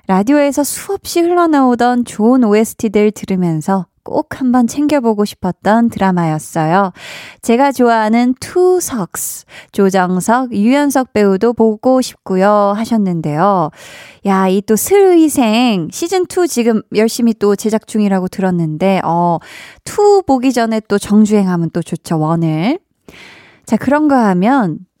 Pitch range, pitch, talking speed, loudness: 190-255 Hz, 220 Hz, 270 characters per minute, -13 LUFS